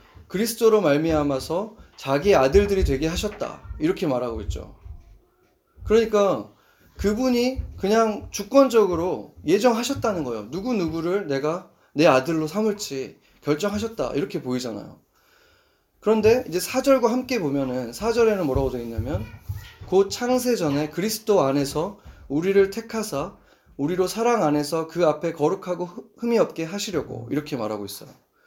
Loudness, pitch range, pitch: -23 LUFS, 145-225 Hz, 195 Hz